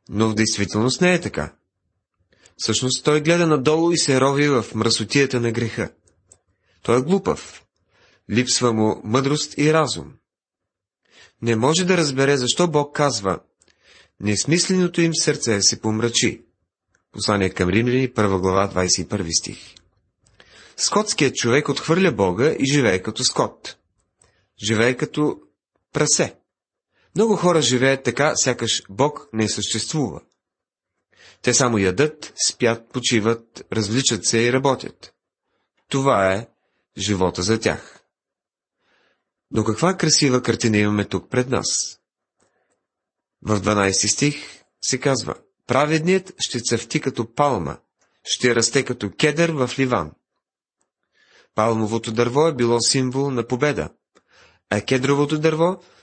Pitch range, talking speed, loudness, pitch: 105-145 Hz, 120 wpm, -20 LUFS, 120 Hz